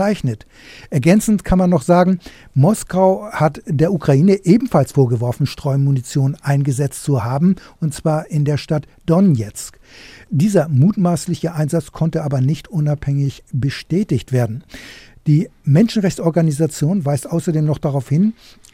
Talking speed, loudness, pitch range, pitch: 120 wpm, -17 LUFS, 140-180 Hz, 155 Hz